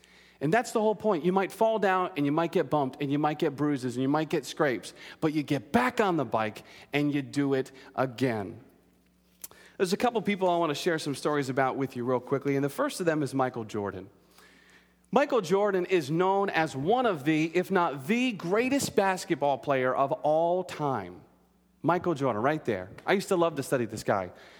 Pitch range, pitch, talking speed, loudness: 135-185 Hz, 150 Hz, 215 wpm, -28 LUFS